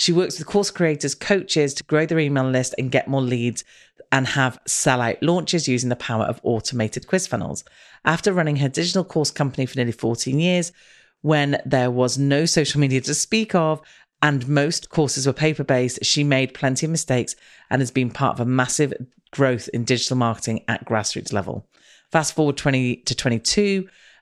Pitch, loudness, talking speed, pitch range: 140 Hz, -21 LUFS, 190 wpm, 125-155 Hz